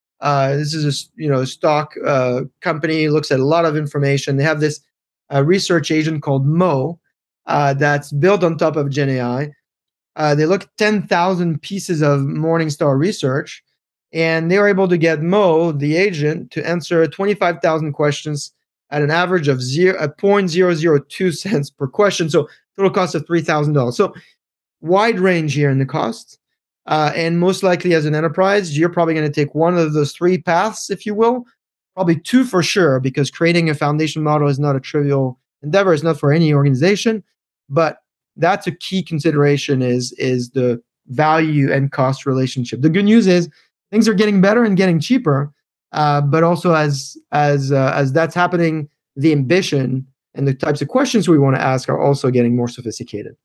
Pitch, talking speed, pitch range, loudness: 155 Hz, 180 wpm, 140-175 Hz, -16 LUFS